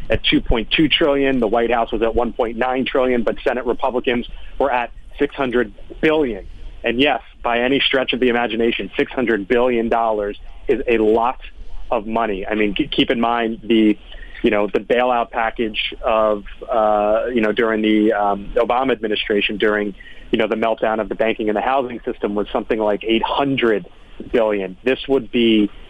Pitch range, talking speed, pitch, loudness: 105-125 Hz, 170 wpm, 115 Hz, -18 LUFS